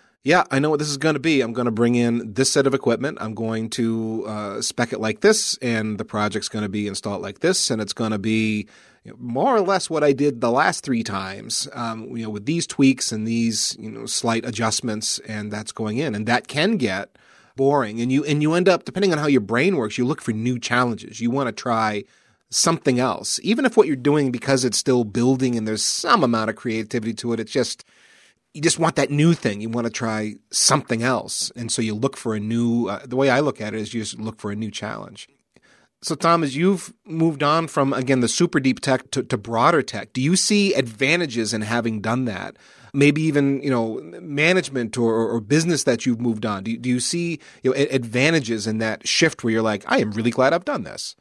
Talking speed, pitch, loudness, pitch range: 240 wpm, 120 Hz, -21 LUFS, 110-145 Hz